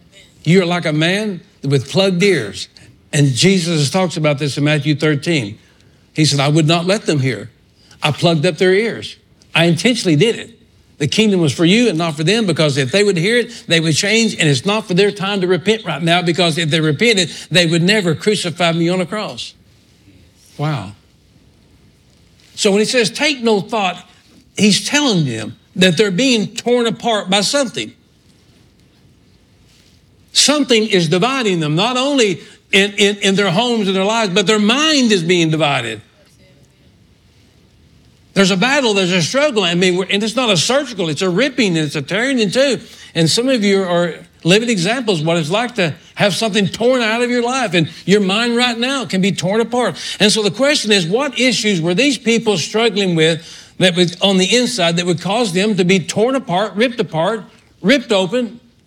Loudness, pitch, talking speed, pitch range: -15 LUFS, 195 Hz, 195 wpm, 165-220 Hz